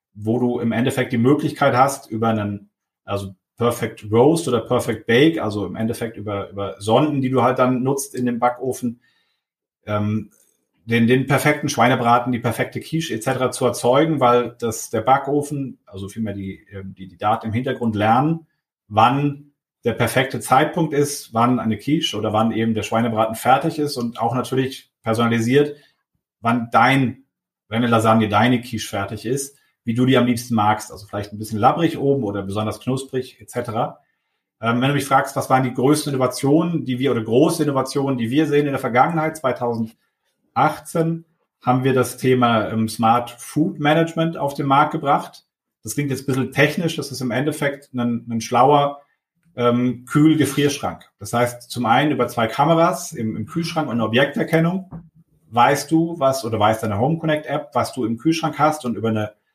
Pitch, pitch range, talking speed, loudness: 125 Hz, 115-145 Hz, 175 wpm, -20 LUFS